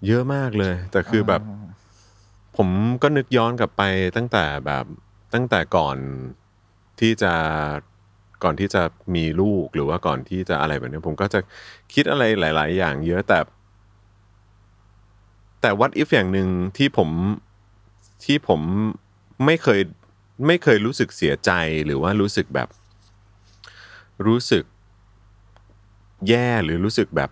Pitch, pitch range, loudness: 100 Hz, 95-105 Hz, -21 LUFS